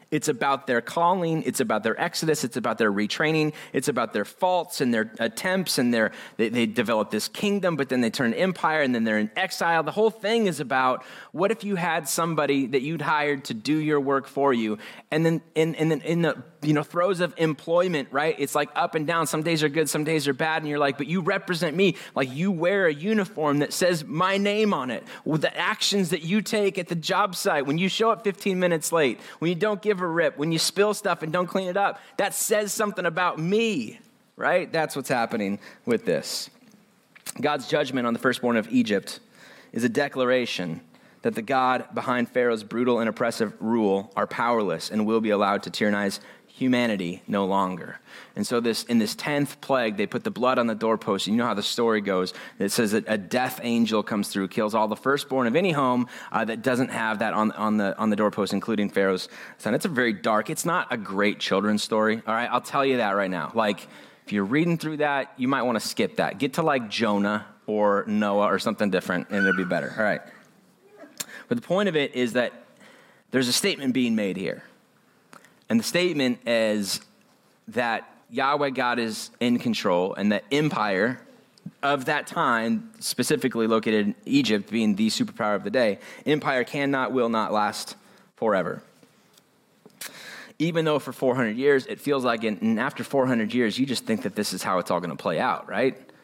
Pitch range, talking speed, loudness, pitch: 115-175 Hz, 210 wpm, -25 LUFS, 145 Hz